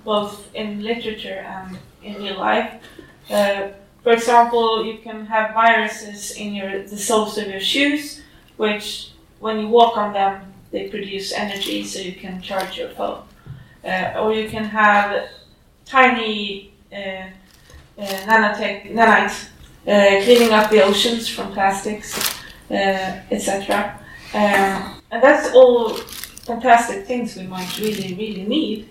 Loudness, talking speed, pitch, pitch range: -18 LUFS, 135 wpm, 210 Hz, 195-225 Hz